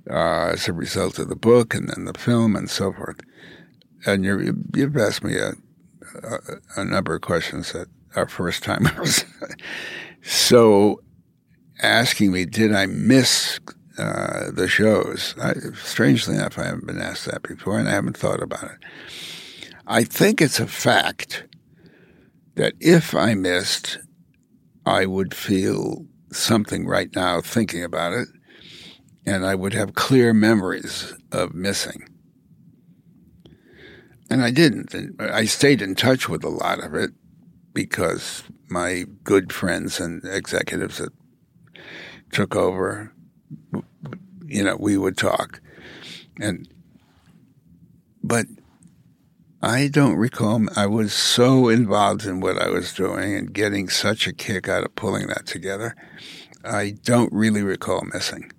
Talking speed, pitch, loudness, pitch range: 140 wpm, 105 Hz, -21 LUFS, 95-120 Hz